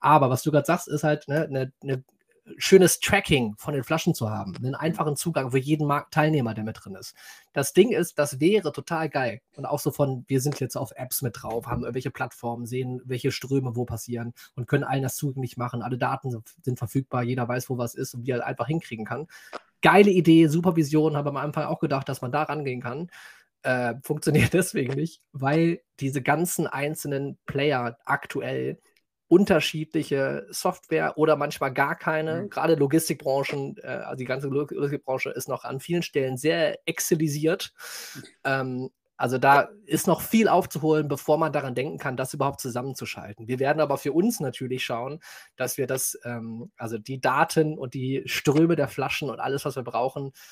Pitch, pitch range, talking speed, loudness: 140 Hz, 130-155 Hz, 185 wpm, -25 LUFS